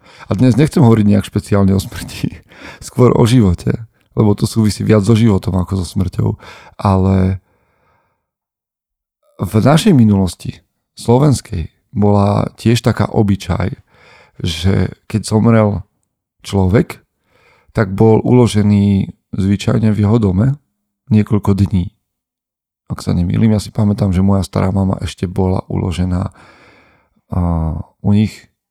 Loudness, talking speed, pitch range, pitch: -14 LUFS, 120 wpm, 95-110 Hz, 100 Hz